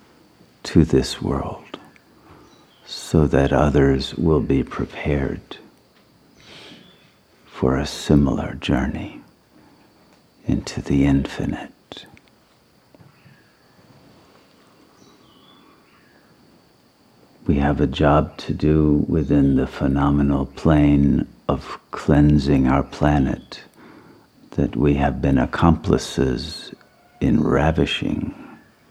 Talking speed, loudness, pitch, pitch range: 75 wpm, -20 LUFS, 70 Hz, 70-75 Hz